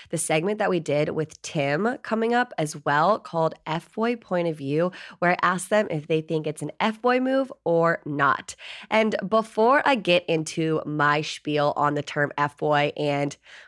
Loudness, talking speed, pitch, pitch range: -24 LUFS, 195 wpm, 165 Hz, 150-210 Hz